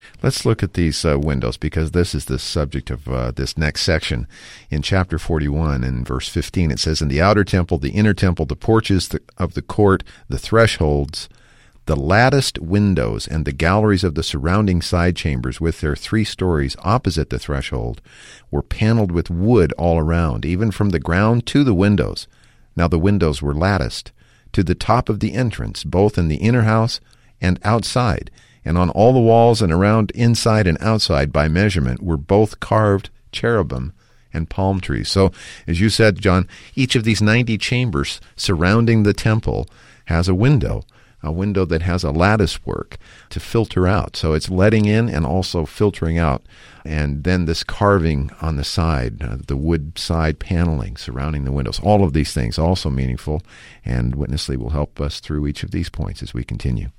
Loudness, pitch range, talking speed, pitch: -18 LUFS, 75-105 Hz, 180 wpm, 90 Hz